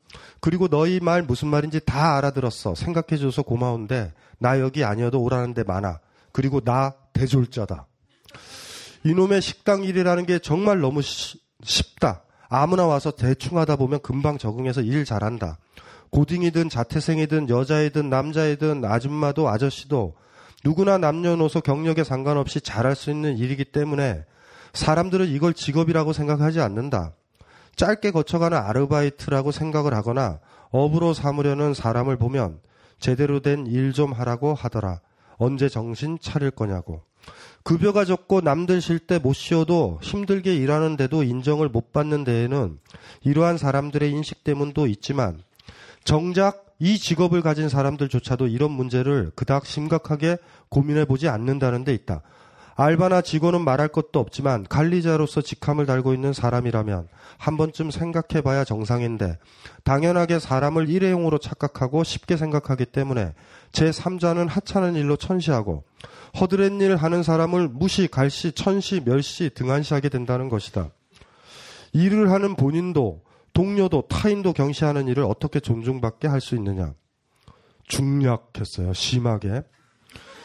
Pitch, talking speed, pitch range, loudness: 145 Hz, 325 characters per minute, 125-160 Hz, -22 LUFS